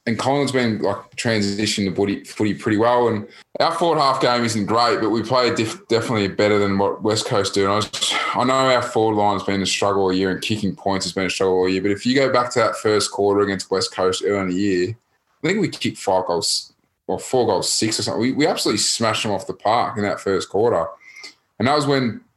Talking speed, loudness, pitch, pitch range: 250 wpm, -20 LUFS, 105 Hz, 100-120 Hz